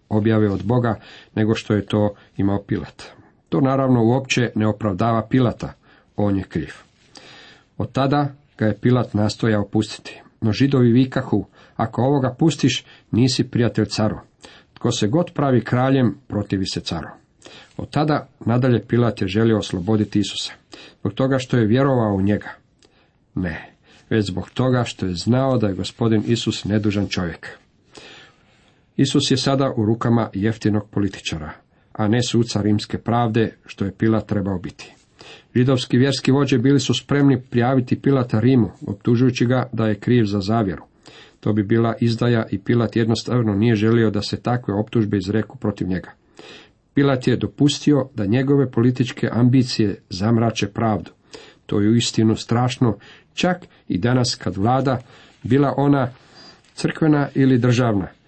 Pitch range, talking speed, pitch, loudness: 105-130 Hz, 145 wpm, 115 Hz, -20 LUFS